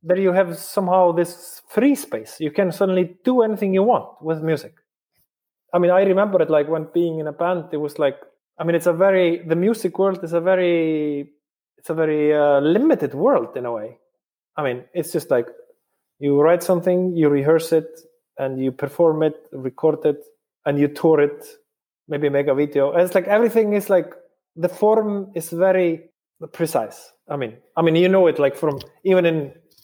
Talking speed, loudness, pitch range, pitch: 195 wpm, -20 LUFS, 155-195 Hz, 175 Hz